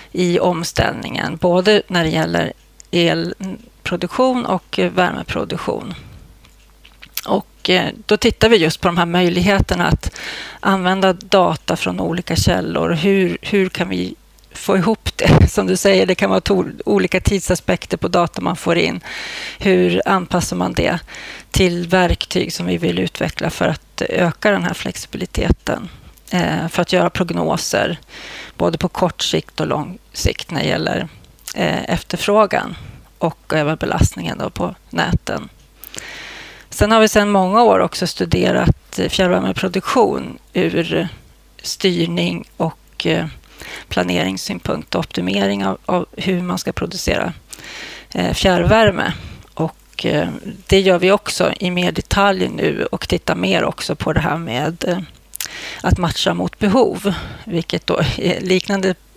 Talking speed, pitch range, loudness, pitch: 130 wpm, 170-195 Hz, -17 LUFS, 180 Hz